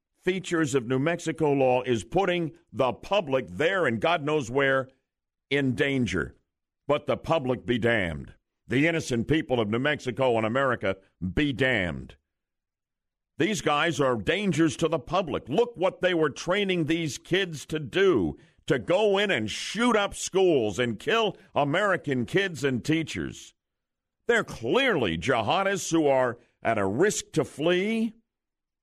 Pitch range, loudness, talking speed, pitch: 120-170 Hz, -26 LUFS, 145 wpm, 145 Hz